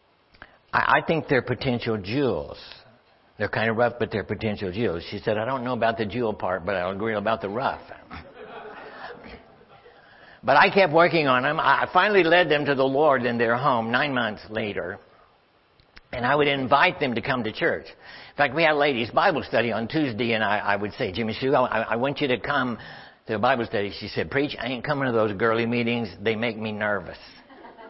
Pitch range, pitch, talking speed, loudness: 110-140 Hz, 120 Hz, 210 wpm, -23 LUFS